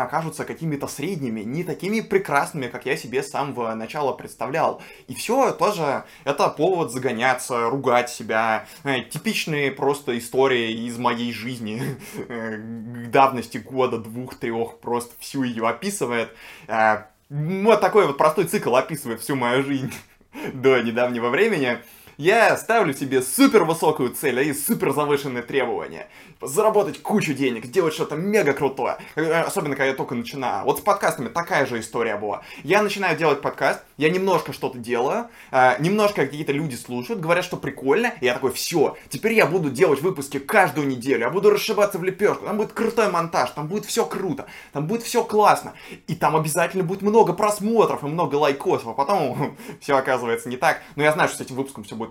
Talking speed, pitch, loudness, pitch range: 160 wpm, 140 Hz, -22 LUFS, 125-190 Hz